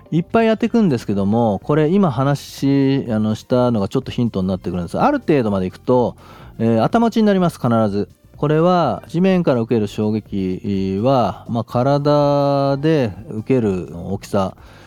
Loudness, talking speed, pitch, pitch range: -18 LUFS, 345 characters per minute, 125 Hz, 105-150 Hz